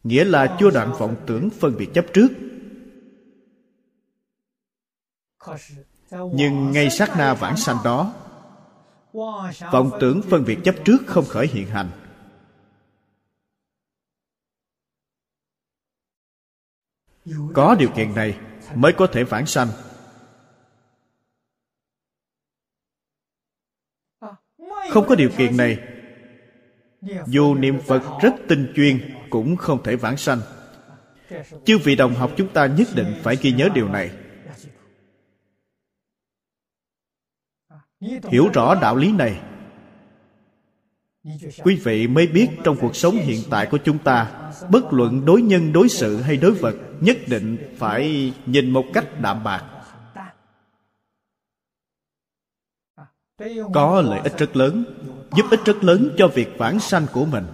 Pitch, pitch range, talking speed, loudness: 140 Hz, 120-185 Hz, 120 wpm, -18 LUFS